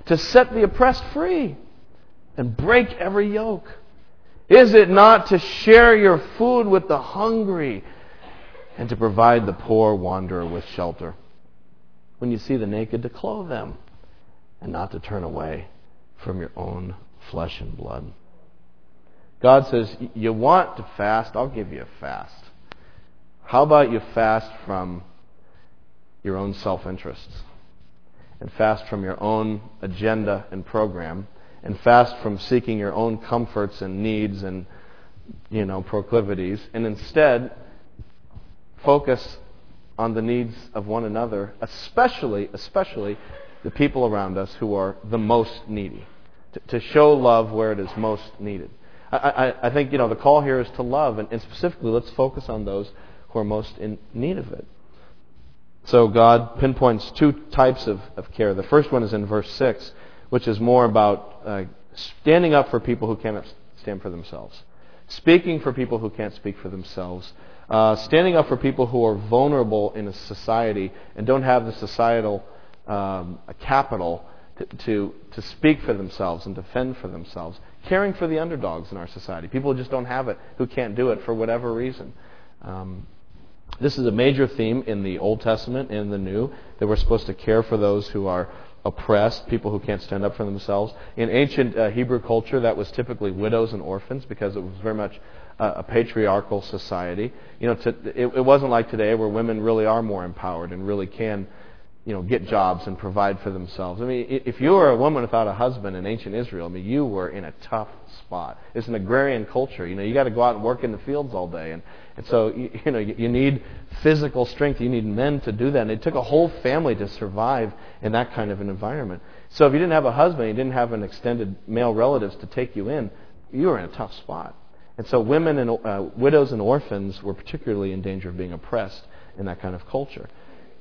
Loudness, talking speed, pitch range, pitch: -21 LUFS, 190 wpm, 95-125 Hz, 110 Hz